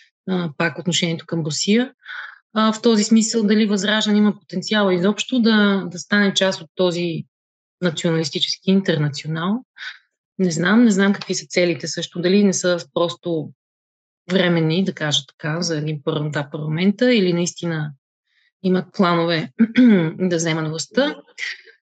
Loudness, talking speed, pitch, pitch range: -19 LUFS, 130 wpm, 180 Hz, 165-205 Hz